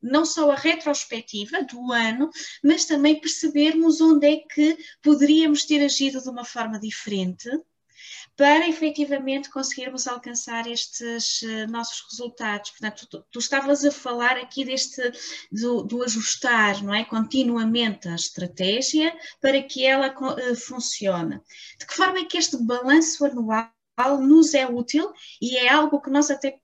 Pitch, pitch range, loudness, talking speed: 265 Hz, 235-295 Hz, -22 LUFS, 145 wpm